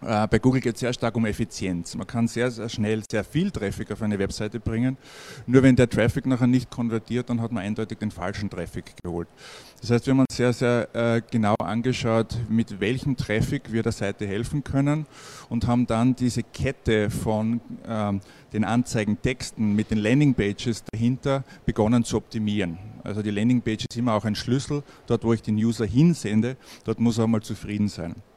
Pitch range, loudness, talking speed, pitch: 105-125 Hz, -25 LUFS, 190 wpm, 115 Hz